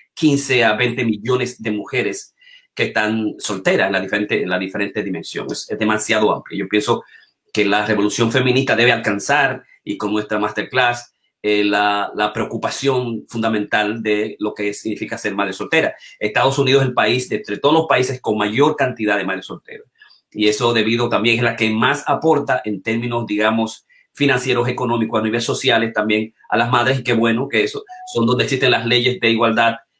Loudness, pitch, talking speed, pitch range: -18 LUFS, 115 Hz, 180 wpm, 105-125 Hz